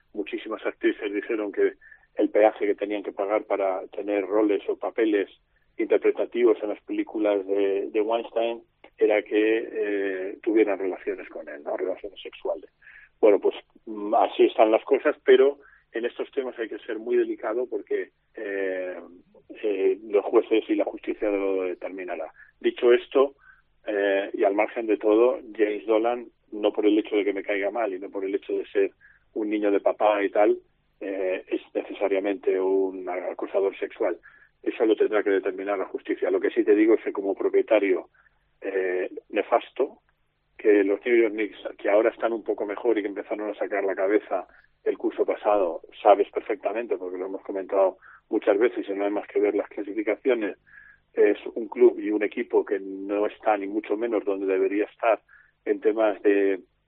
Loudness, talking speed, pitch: -25 LUFS, 175 wpm, 345 Hz